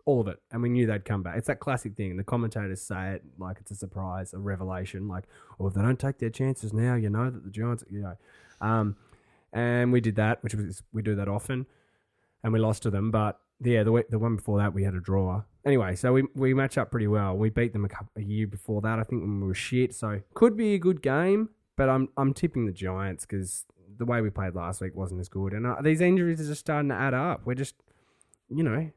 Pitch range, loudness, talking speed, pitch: 100-125 Hz, -28 LUFS, 265 wpm, 110 Hz